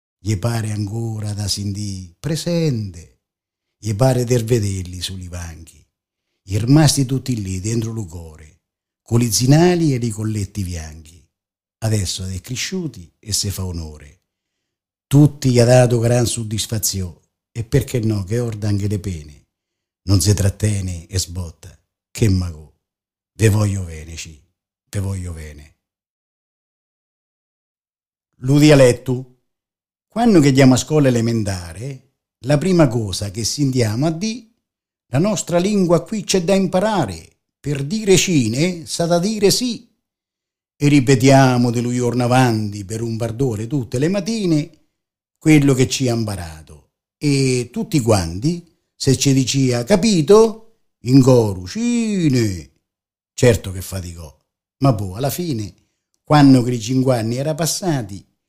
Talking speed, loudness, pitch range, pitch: 135 wpm, -17 LUFS, 95-140 Hz, 115 Hz